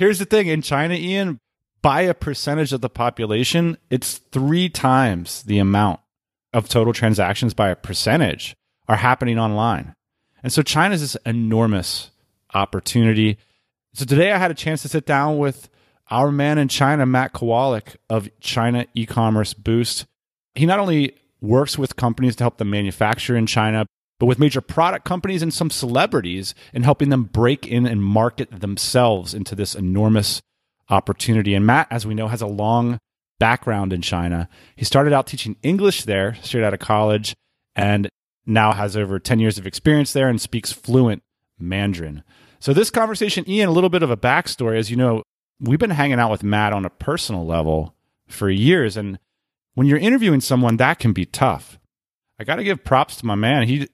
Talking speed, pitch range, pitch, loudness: 180 wpm, 105-140 Hz, 120 Hz, -19 LUFS